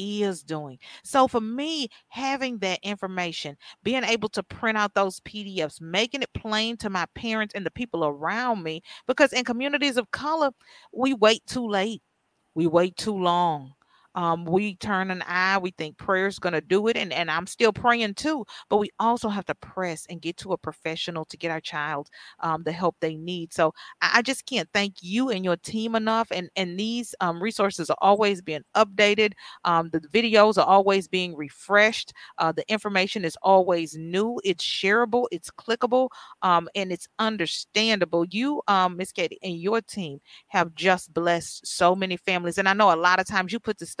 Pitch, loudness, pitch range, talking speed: 195 Hz, -25 LUFS, 170-225 Hz, 190 wpm